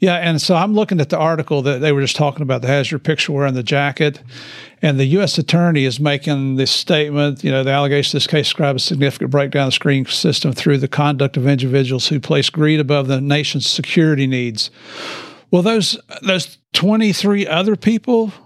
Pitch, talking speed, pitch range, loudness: 145 Hz, 210 wpm, 140-165 Hz, -16 LUFS